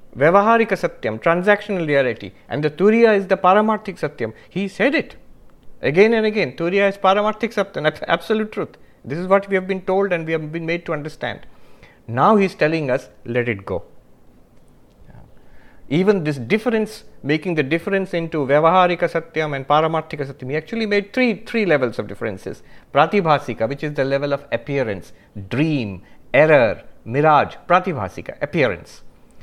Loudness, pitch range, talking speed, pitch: -19 LUFS, 140-200 Hz, 160 wpm, 165 Hz